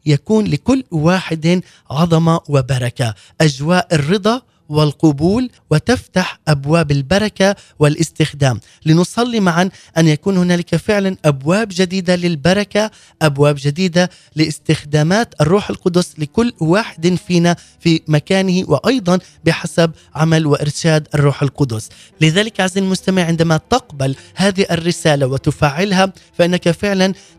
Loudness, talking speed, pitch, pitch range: -15 LUFS, 105 wpm, 170 Hz, 150-190 Hz